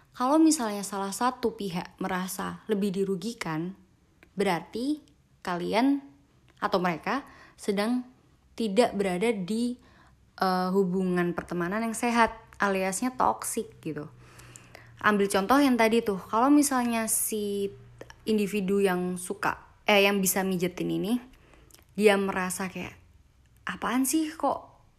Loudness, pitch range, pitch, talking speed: -27 LUFS, 185-230 Hz, 200 Hz, 110 wpm